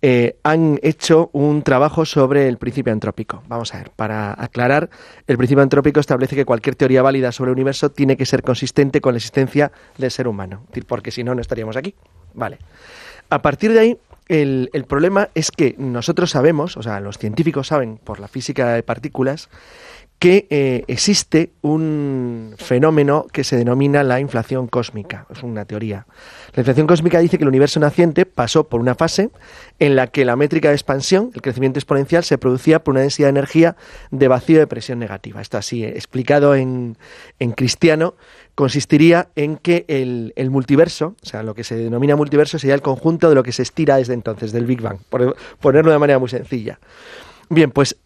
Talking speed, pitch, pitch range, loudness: 190 wpm, 135 Hz, 125-155 Hz, -16 LUFS